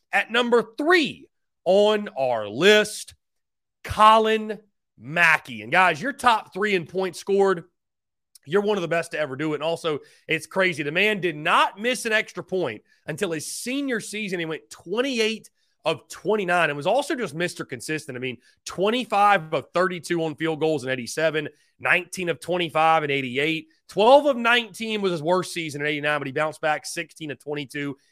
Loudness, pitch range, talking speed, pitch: -23 LUFS, 155-215 Hz, 175 wpm, 180 Hz